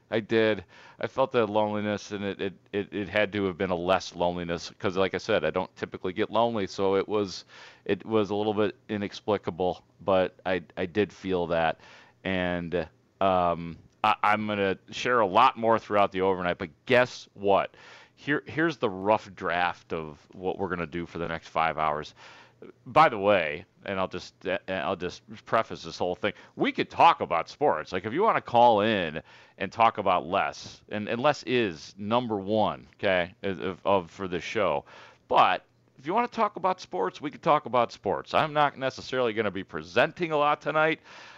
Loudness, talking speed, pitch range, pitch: -27 LUFS, 195 wpm, 90-115 Hz, 100 Hz